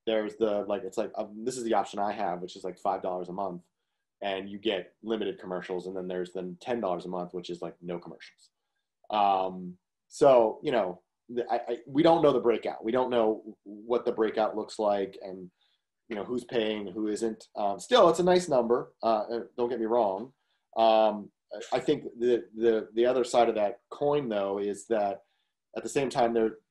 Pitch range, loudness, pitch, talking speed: 95-120 Hz, -29 LUFS, 105 Hz, 205 wpm